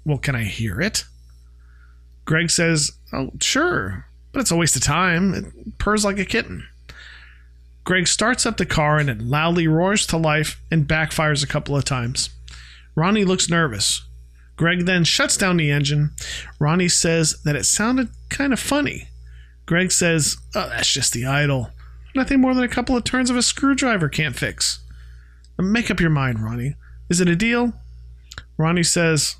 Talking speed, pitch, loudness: 170 wpm, 150 Hz, -19 LUFS